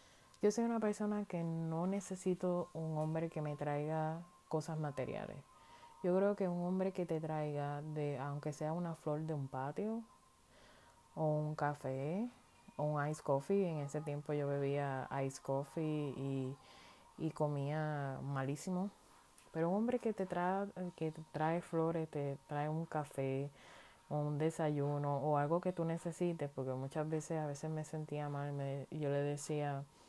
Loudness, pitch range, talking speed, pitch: -40 LUFS, 145-170 Hz, 165 wpm, 155 Hz